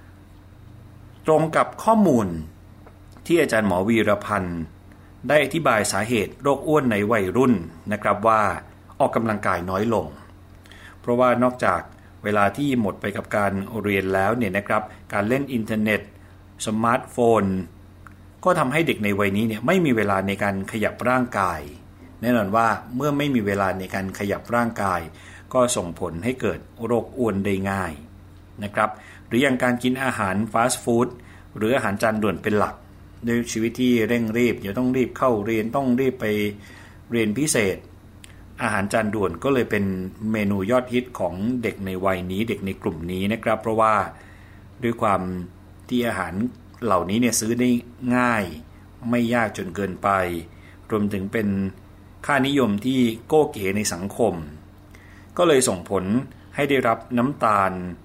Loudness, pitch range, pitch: -22 LUFS, 95-120 Hz, 105 Hz